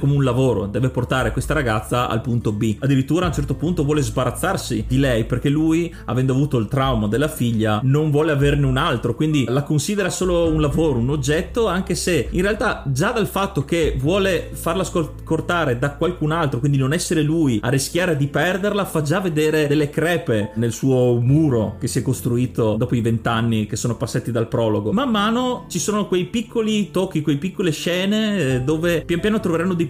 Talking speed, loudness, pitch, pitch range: 195 wpm, -20 LUFS, 150 Hz, 125-170 Hz